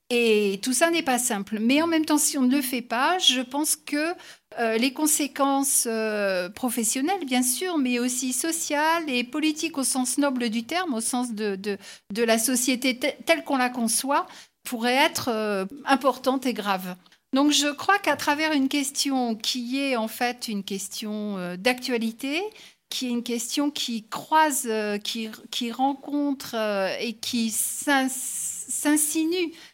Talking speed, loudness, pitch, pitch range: 155 wpm, -24 LUFS, 255 Hz, 230-290 Hz